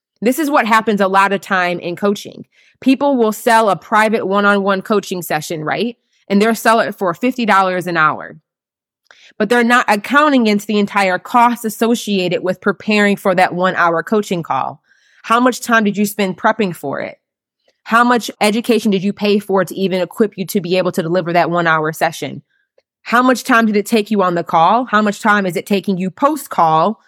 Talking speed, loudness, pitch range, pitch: 210 wpm, -15 LUFS, 185-230 Hz, 205 Hz